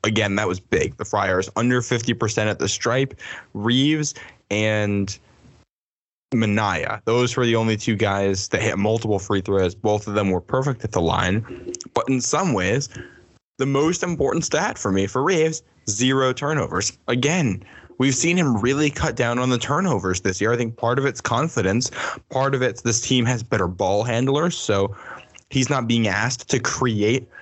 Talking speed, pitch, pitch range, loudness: 175 wpm, 115 Hz, 105-130 Hz, -21 LUFS